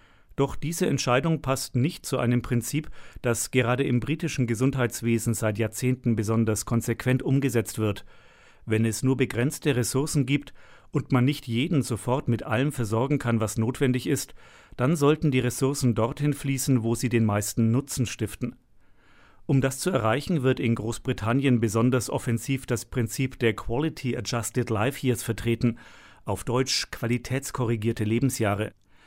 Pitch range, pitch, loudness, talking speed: 115-135 Hz, 125 Hz, -26 LUFS, 145 wpm